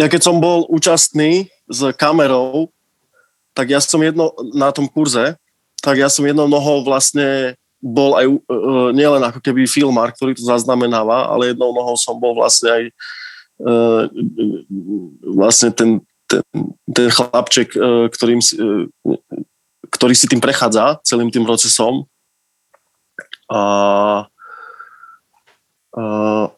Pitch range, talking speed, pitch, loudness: 115-145 Hz, 130 wpm, 130 Hz, -14 LUFS